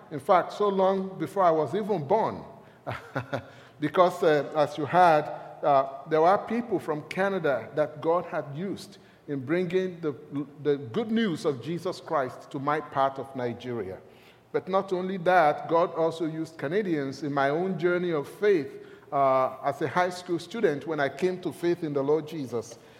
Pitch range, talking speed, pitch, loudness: 145-180 Hz, 175 wpm, 160 Hz, -27 LUFS